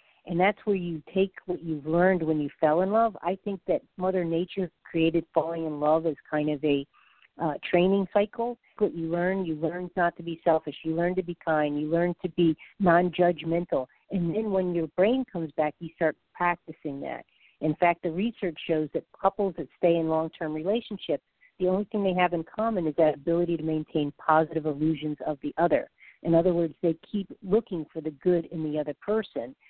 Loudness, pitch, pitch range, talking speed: -27 LUFS, 170 Hz, 160-185 Hz, 210 wpm